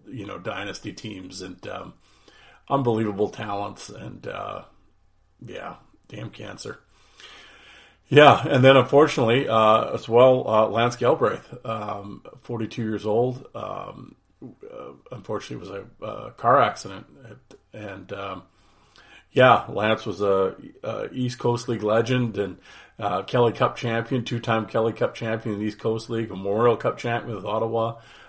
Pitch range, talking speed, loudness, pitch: 105-120 Hz, 140 wpm, -22 LUFS, 115 Hz